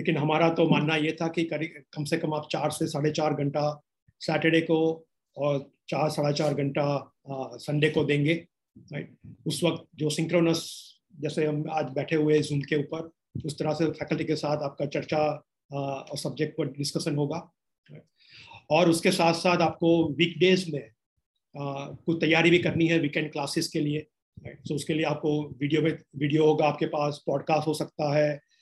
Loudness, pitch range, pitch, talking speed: -27 LUFS, 145-160 Hz, 155 Hz, 175 wpm